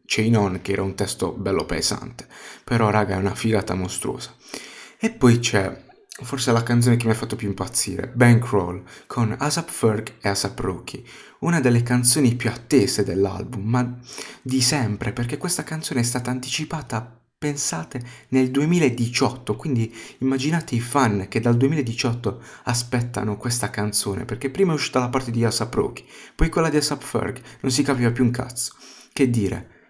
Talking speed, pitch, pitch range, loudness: 165 wpm, 120 Hz, 110-135 Hz, -22 LUFS